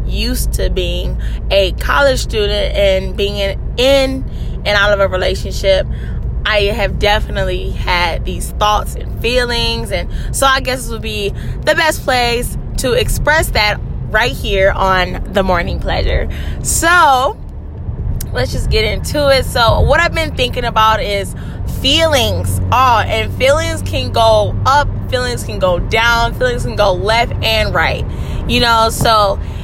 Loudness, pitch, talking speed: -14 LUFS, 190 Hz, 150 wpm